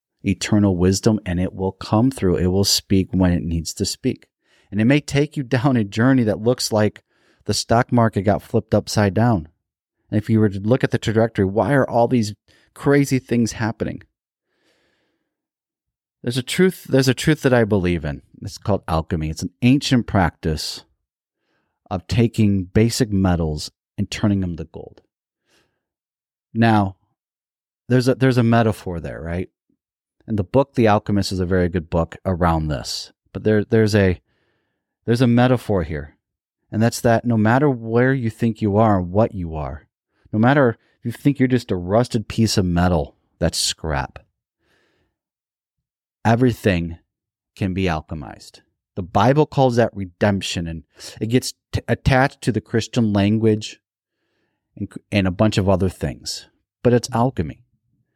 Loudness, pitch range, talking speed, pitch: -19 LUFS, 95-120 Hz, 165 wpm, 105 Hz